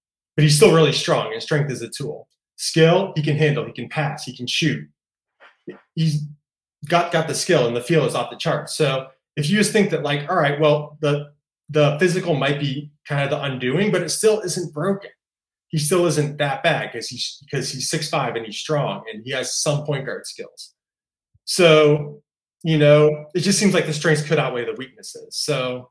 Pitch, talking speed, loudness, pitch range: 150 Hz, 210 wpm, -20 LUFS, 140-165 Hz